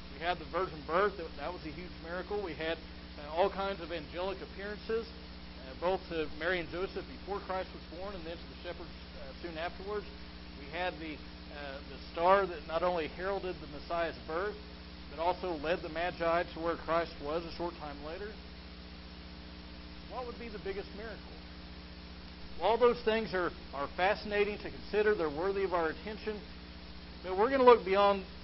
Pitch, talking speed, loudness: 170 Hz, 185 wpm, -34 LUFS